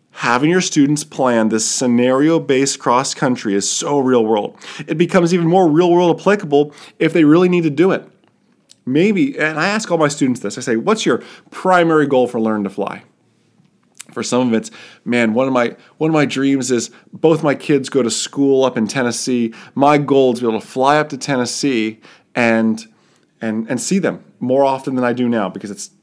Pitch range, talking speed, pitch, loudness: 120-155 Hz, 205 wpm, 135 Hz, -16 LUFS